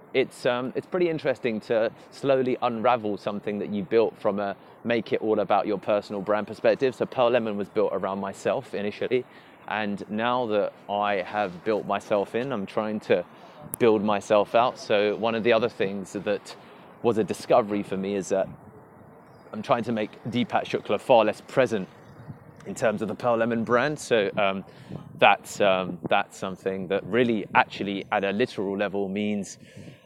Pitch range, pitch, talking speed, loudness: 100-115 Hz, 105 Hz, 175 wpm, -26 LUFS